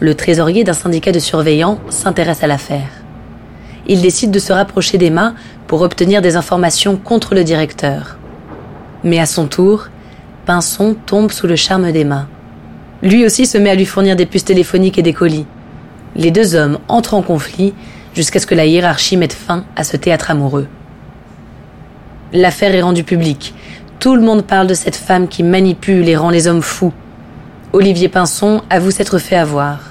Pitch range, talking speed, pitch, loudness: 160-195 Hz, 175 wpm, 175 Hz, -12 LUFS